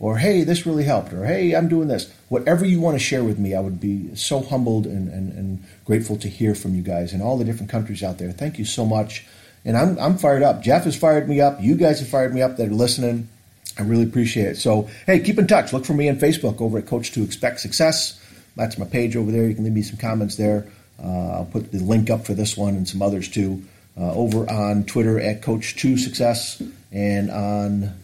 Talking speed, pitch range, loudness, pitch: 240 wpm, 100-130 Hz, -21 LUFS, 110 Hz